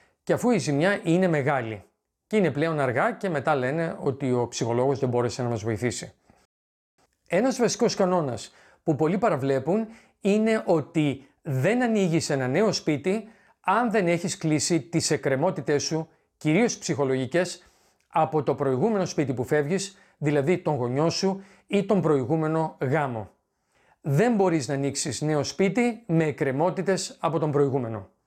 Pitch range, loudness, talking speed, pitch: 140-190 Hz, -25 LUFS, 145 wpm, 160 Hz